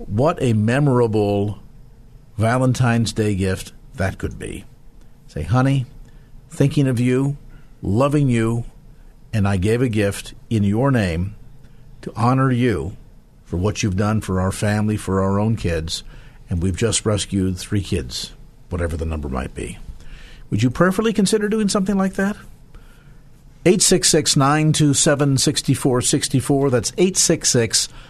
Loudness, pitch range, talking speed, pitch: -19 LUFS, 105-140 Hz, 130 wpm, 120 Hz